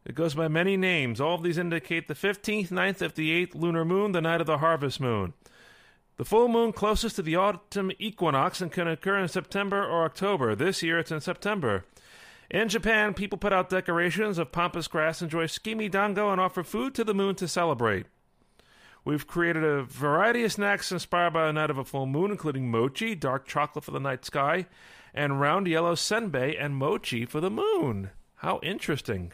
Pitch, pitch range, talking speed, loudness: 175 Hz, 150-200 Hz, 195 wpm, -27 LUFS